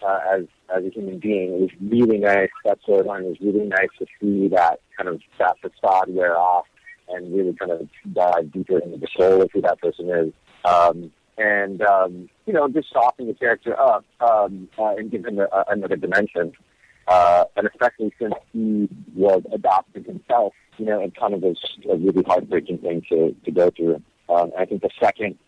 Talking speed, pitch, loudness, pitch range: 205 wpm, 95 Hz, -21 LUFS, 90-105 Hz